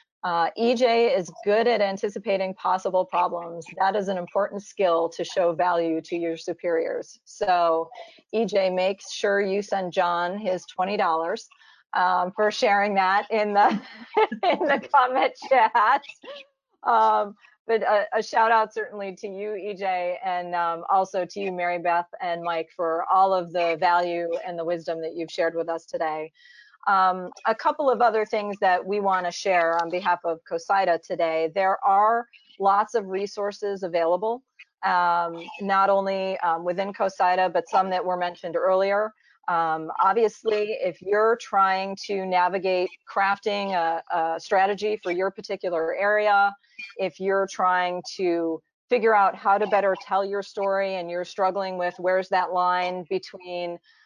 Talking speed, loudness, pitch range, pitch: 160 wpm, -24 LUFS, 175-205 Hz, 190 Hz